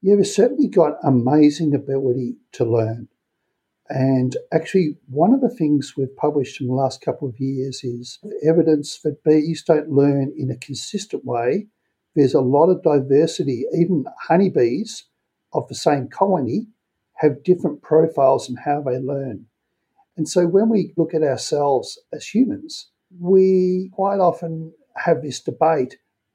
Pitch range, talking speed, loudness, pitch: 135-190 Hz, 150 wpm, -19 LUFS, 155 Hz